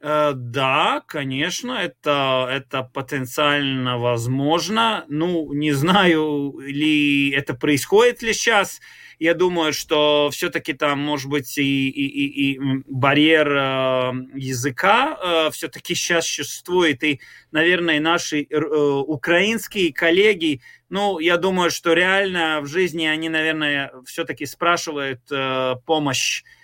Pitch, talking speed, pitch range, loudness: 150 Hz, 105 wpm, 140-170 Hz, -20 LUFS